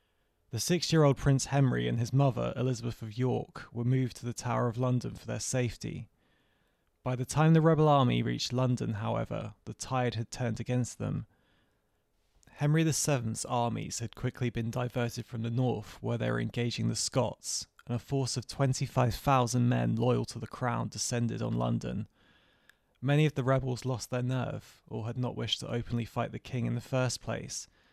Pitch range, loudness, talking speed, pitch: 115-135 Hz, -31 LUFS, 185 wpm, 125 Hz